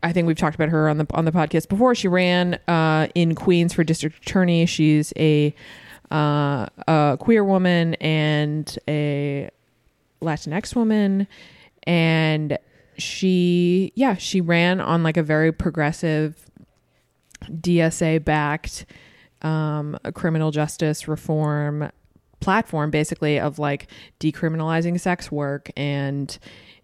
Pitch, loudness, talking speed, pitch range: 155 Hz, -21 LUFS, 120 wpm, 150-170 Hz